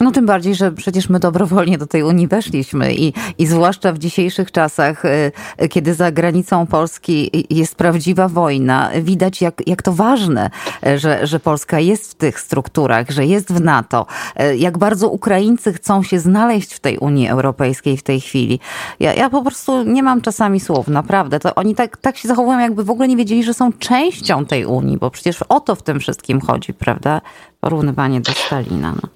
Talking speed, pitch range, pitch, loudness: 185 wpm, 150-205 Hz, 175 Hz, -15 LUFS